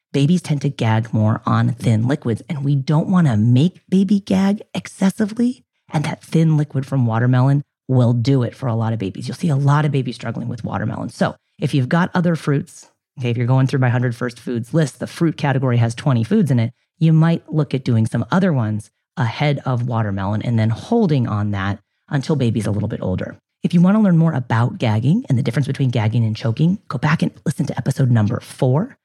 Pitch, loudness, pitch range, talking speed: 135 Hz, -19 LUFS, 120-160 Hz, 225 wpm